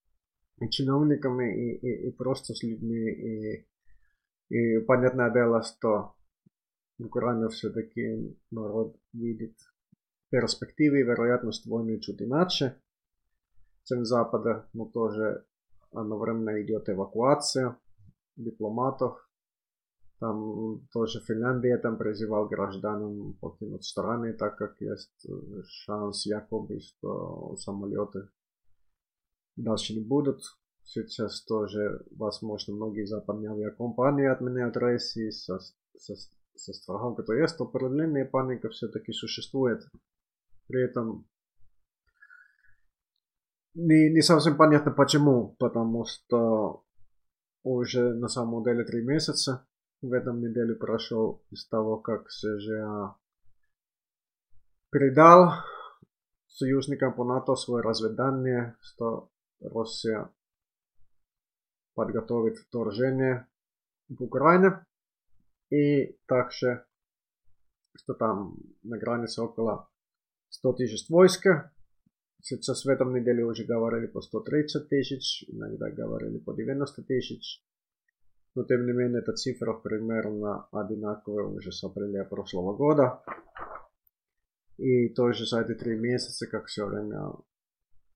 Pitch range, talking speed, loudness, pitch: 105-125 Hz, 100 wpm, -28 LUFS, 115 Hz